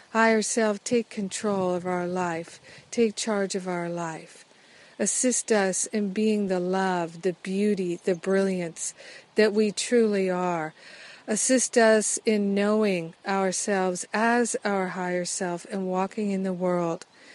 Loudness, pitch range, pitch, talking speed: -26 LUFS, 180-215 Hz, 195 Hz, 140 wpm